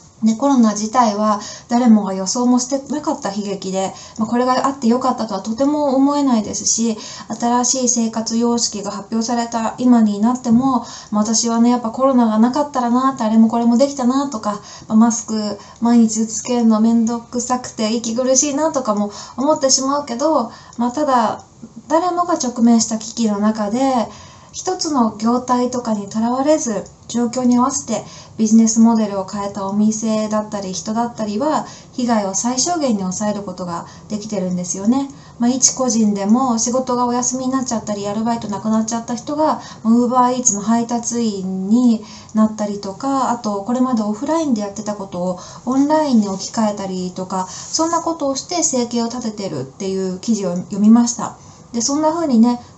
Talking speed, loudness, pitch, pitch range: 375 characters per minute, -17 LUFS, 230 Hz, 210-250 Hz